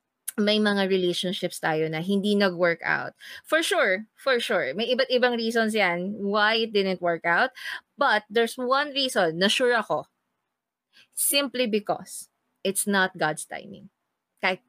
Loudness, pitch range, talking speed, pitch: -24 LUFS, 185-240 Hz, 145 wpm, 205 Hz